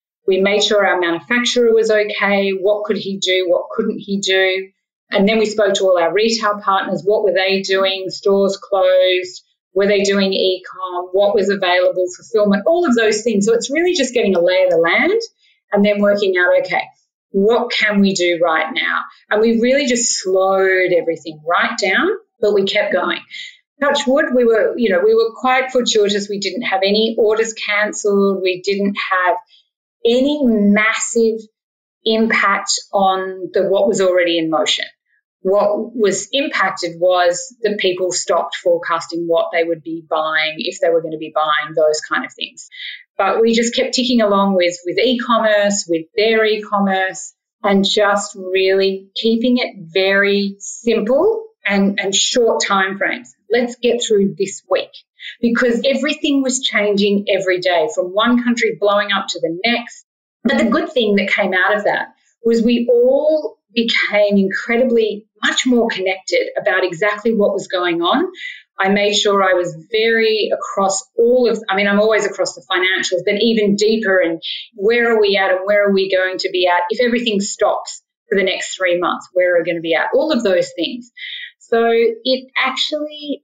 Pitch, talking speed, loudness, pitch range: 205 Hz, 180 wpm, -16 LUFS, 190-235 Hz